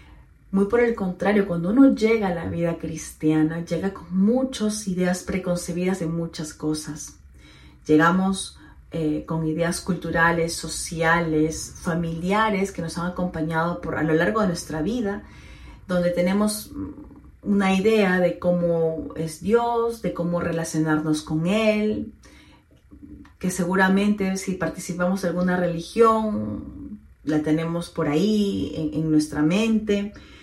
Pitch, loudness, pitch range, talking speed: 175 Hz, -23 LUFS, 160-195 Hz, 130 wpm